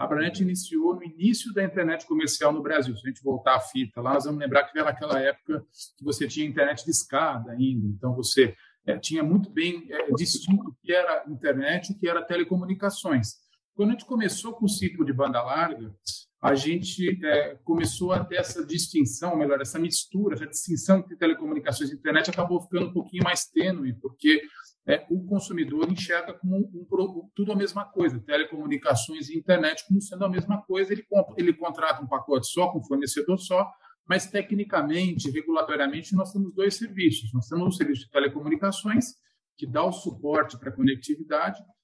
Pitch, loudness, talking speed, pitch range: 170 Hz, -26 LUFS, 185 wpm, 145-190 Hz